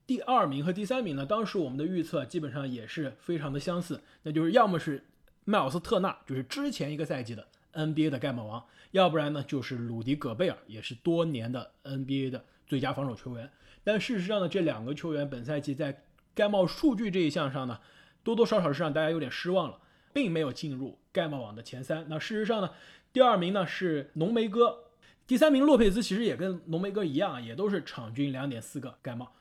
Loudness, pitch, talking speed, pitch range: -30 LUFS, 155 Hz, 335 characters per minute, 135-190 Hz